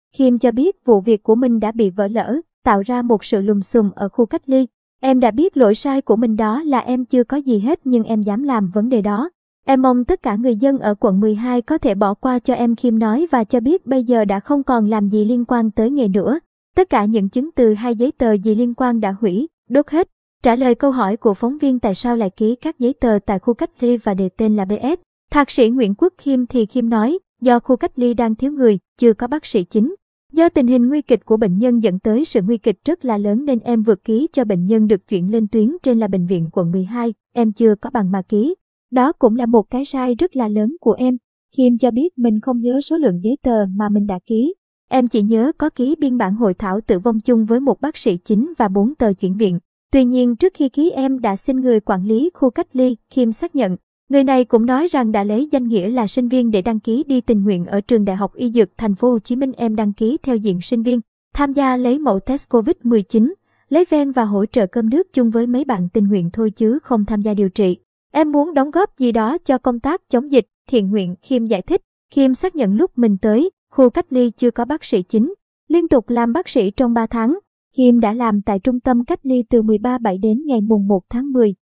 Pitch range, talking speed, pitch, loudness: 220-265 Hz, 260 wpm, 240 Hz, -17 LUFS